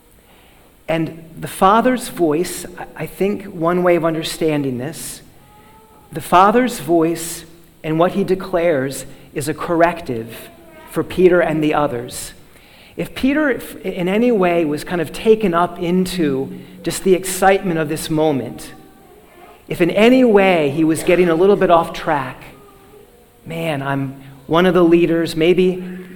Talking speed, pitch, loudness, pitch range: 140 wpm, 170 Hz, -16 LUFS, 155-185 Hz